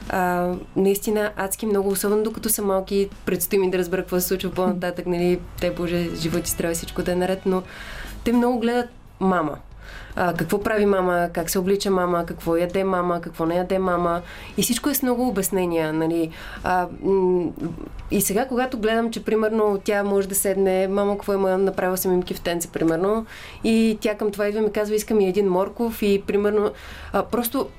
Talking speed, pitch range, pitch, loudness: 190 wpm, 180-210 Hz, 195 Hz, -22 LUFS